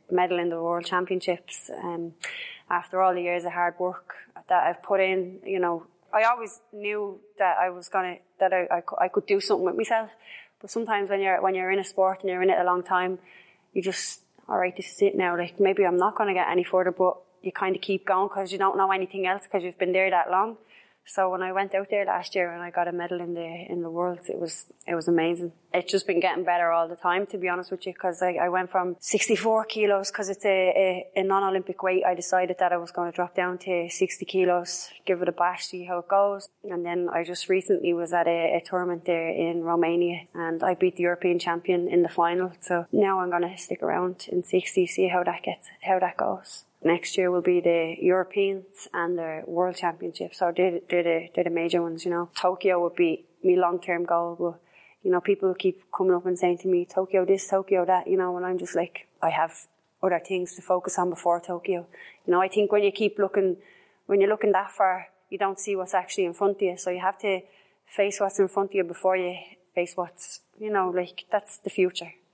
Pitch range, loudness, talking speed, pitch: 175-195 Hz, -26 LUFS, 245 wpm, 185 Hz